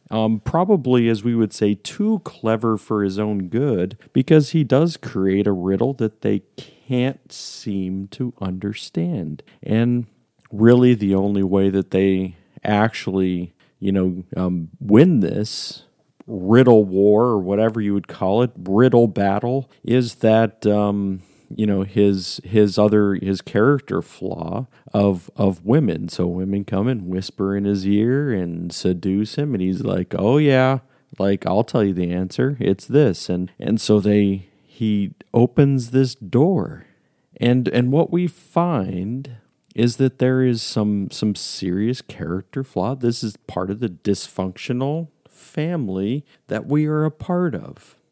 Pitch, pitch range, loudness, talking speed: 105 Hz, 95-130 Hz, -20 LUFS, 150 wpm